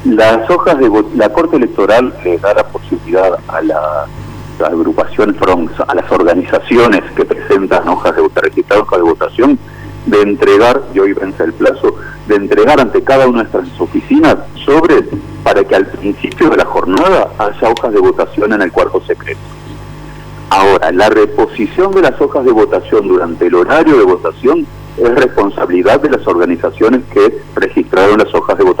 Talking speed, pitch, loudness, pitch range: 175 wpm, 390 Hz, -10 LUFS, 360-415 Hz